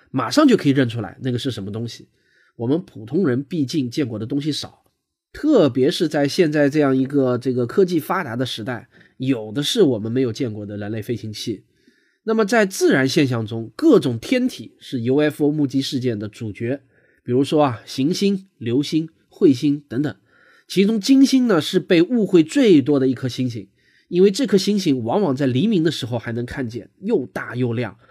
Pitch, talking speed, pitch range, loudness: 135 Hz, 290 characters per minute, 120-165 Hz, -20 LUFS